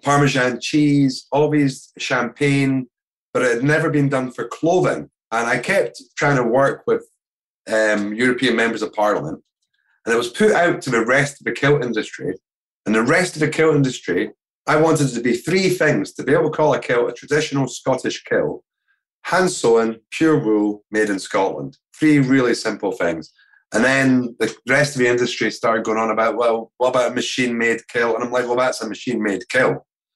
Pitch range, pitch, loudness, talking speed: 115-150 Hz, 130 Hz, -19 LUFS, 195 wpm